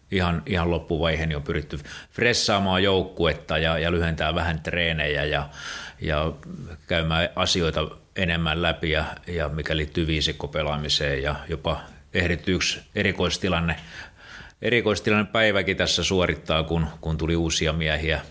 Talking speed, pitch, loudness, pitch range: 120 wpm, 85 Hz, -24 LUFS, 80-90 Hz